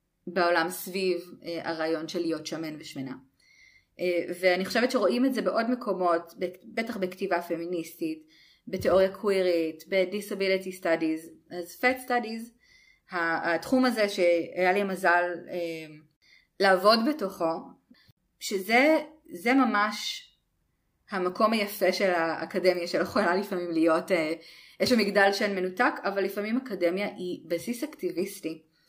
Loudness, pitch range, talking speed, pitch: -27 LUFS, 170-210 Hz, 110 wpm, 185 Hz